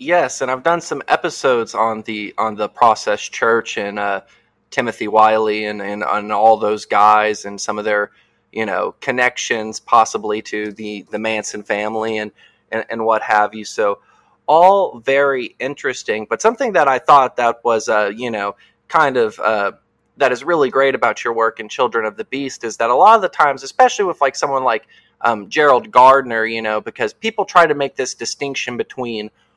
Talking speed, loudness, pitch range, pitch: 190 wpm, -17 LUFS, 105-135 Hz, 110 Hz